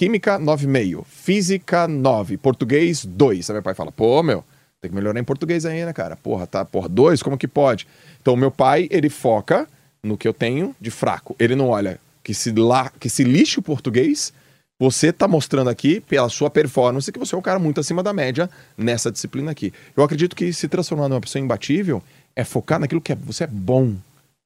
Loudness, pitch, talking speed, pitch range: -20 LUFS, 140 Hz, 205 wpm, 125-165 Hz